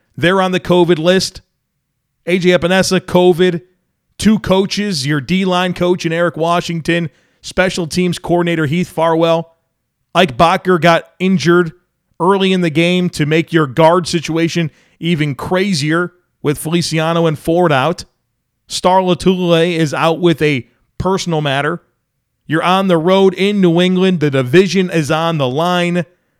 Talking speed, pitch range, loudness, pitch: 145 wpm, 160-180 Hz, -14 LUFS, 170 Hz